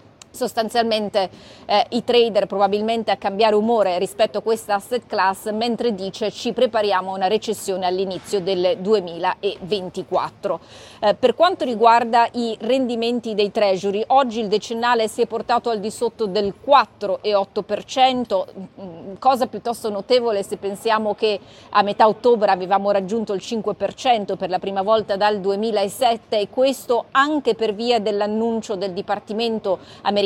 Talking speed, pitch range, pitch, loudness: 140 wpm, 200-235 Hz, 215 Hz, -20 LUFS